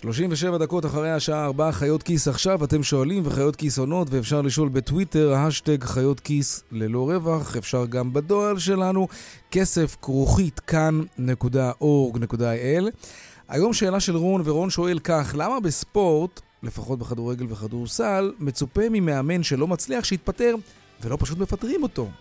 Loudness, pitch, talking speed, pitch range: -23 LUFS, 150 Hz, 130 wpm, 130-180 Hz